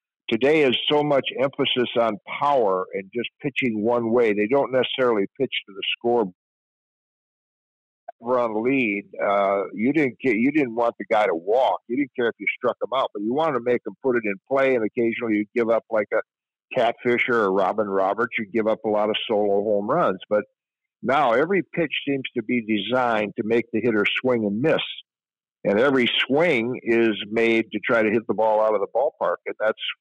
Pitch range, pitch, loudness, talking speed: 105-125 Hz, 115 Hz, -22 LUFS, 205 wpm